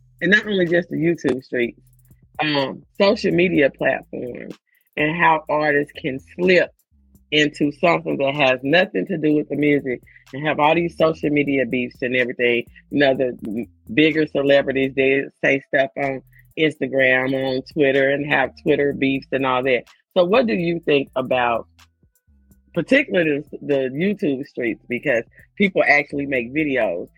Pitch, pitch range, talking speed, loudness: 140 Hz, 130-155 Hz, 150 wpm, -19 LUFS